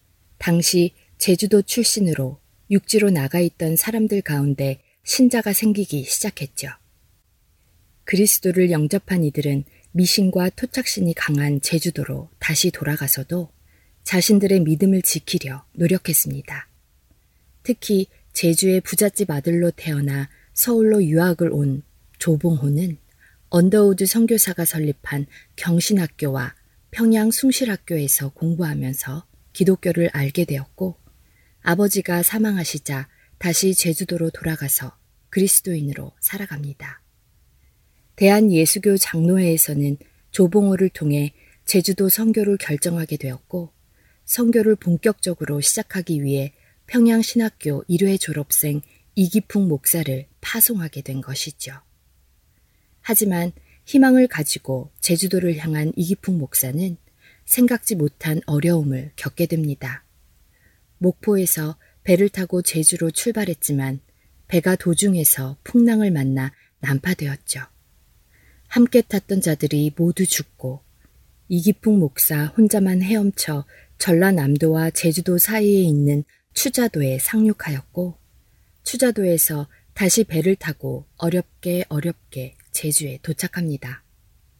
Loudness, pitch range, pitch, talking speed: -19 LUFS, 145-195 Hz, 170 Hz, 265 characters per minute